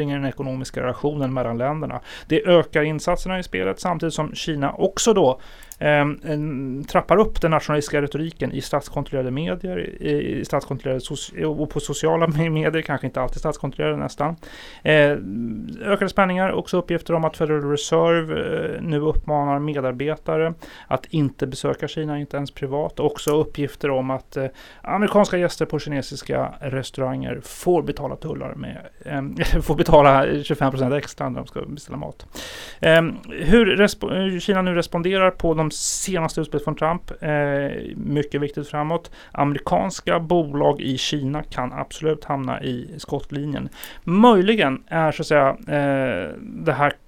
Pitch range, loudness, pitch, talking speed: 140-165 Hz, -22 LUFS, 150 Hz, 140 wpm